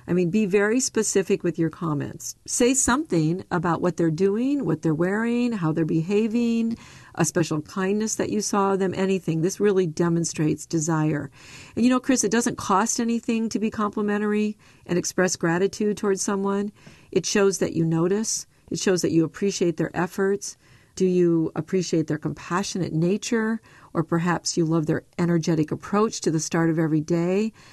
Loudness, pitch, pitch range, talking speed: -24 LUFS, 185 Hz, 165-210 Hz, 170 wpm